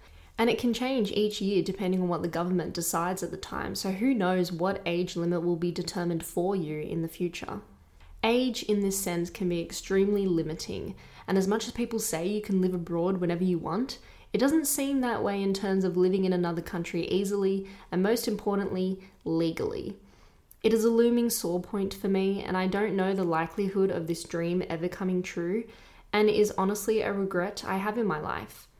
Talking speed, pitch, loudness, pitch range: 205 wpm, 190 Hz, -29 LUFS, 175-210 Hz